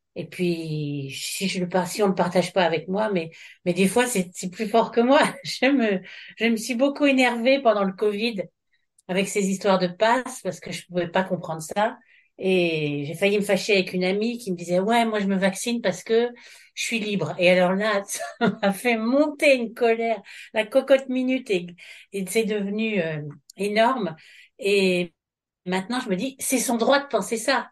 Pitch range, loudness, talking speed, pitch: 185-235 Hz, -23 LUFS, 200 wpm, 205 Hz